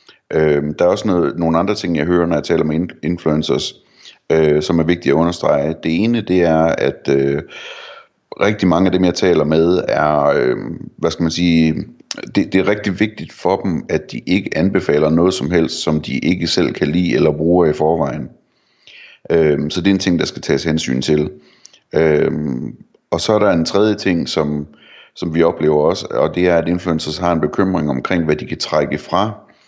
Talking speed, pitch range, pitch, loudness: 205 wpm, 75-90 Hz, 80 Hz, -16 LUFS